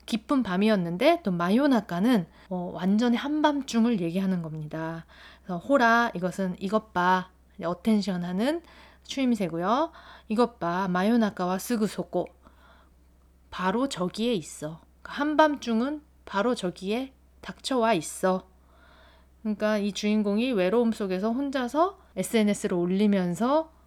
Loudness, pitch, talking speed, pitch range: -26 LUFS, 210 Hz, 270 characters per minute, 180-240 Hz